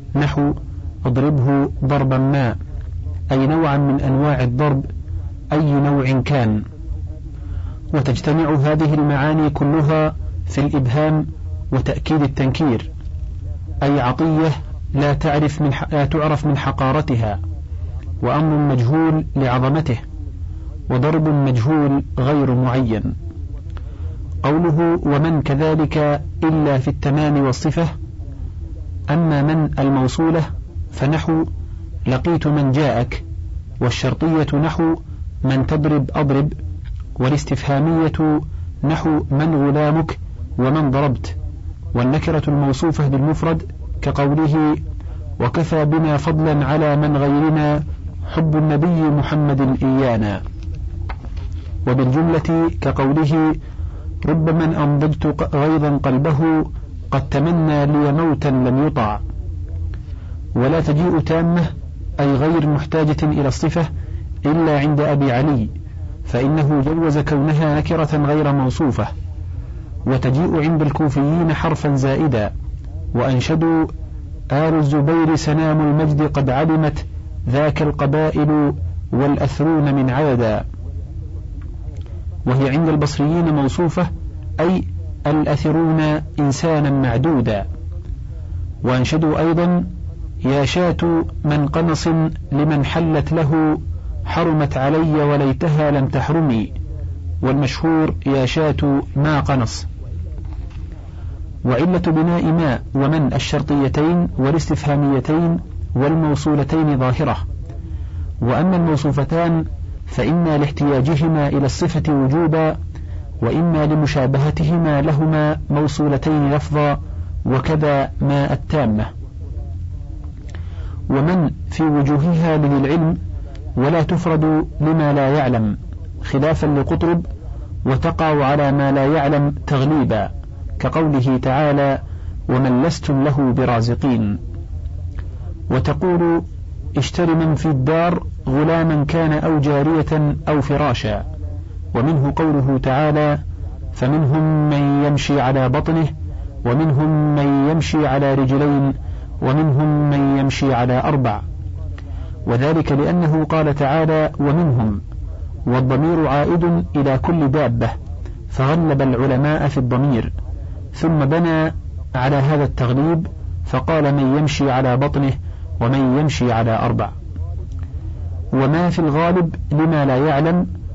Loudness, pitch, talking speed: -17 LUFS, 140 Hz, 90 wpm